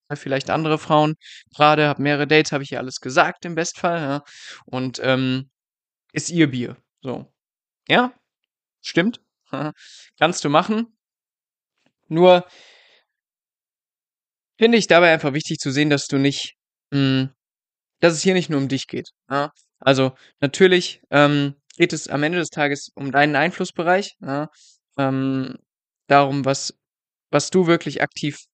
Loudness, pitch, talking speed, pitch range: -20 LUFS, 150 Hz, 140 wpm, 140-170 Hz